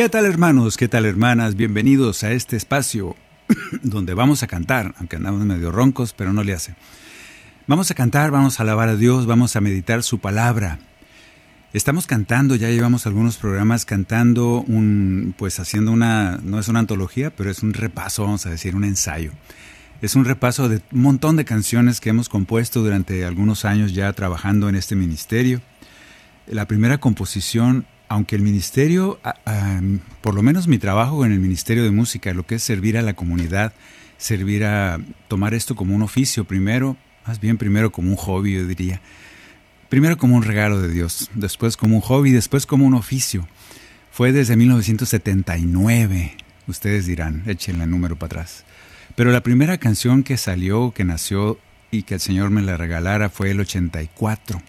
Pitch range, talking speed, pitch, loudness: 95-120 Hz, 175 wpm, 105 Hz, -19 LUFS